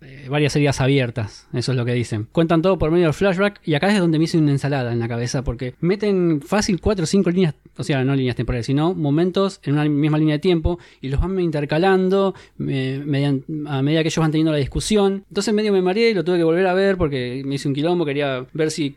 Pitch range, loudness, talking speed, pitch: 135-180 Hz, -20 LUFS, 250 wpm, 155 Hz